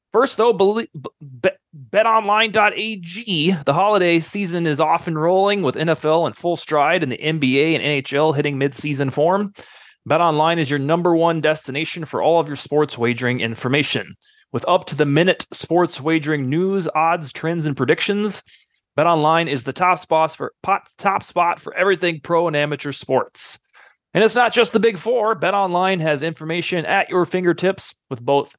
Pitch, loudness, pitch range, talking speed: 165 Hz, -19 LUFS, 150-185 Hz, 160 wpm